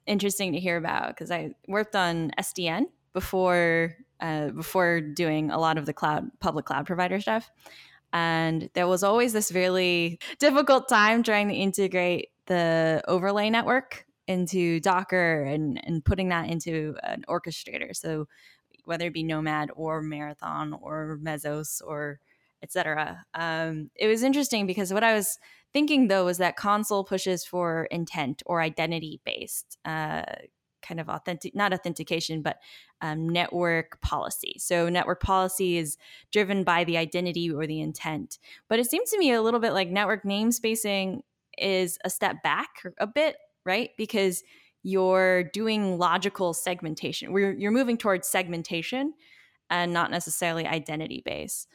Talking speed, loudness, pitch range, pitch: 150 wpm, -27 LUFS, 165-200 Hz, 180 Hz